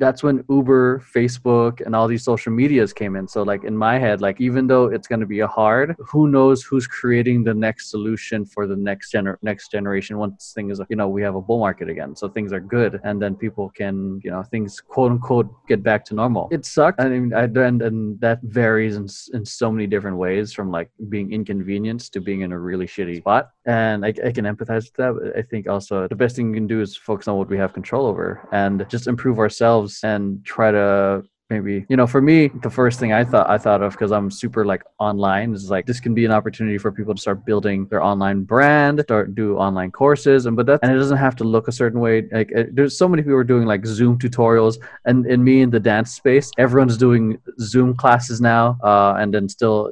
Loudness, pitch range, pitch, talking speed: -19 LUFS, 100-125 Hz, 110 Hz, 235 wpm